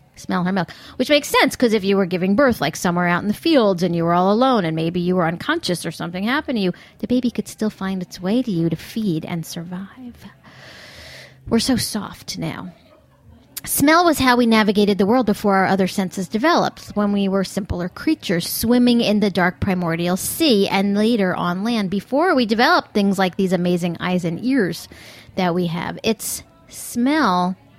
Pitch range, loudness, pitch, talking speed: 180-240 Hz, -19 LUFS, 200 Hz, 200 wpm